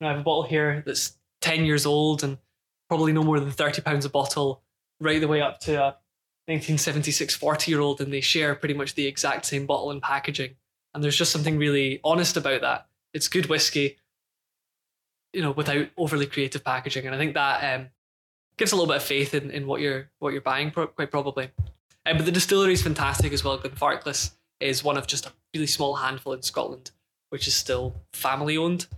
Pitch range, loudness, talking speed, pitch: 135-155 Hz, -25 LUFS, 215 wpm, 145 Hz